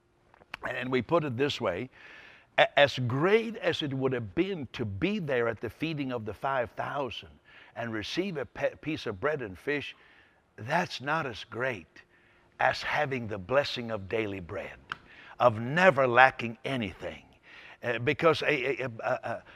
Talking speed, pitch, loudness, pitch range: 165 wpm, 130 Hz, -29 LUFS, 115-150 Hz